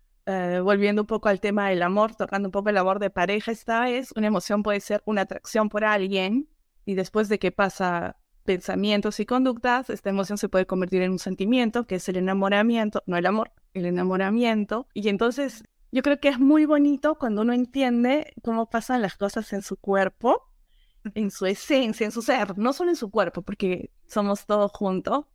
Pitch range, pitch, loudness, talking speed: 195-235 Hz, 210 Hz, -24 LUFS, 195 wpm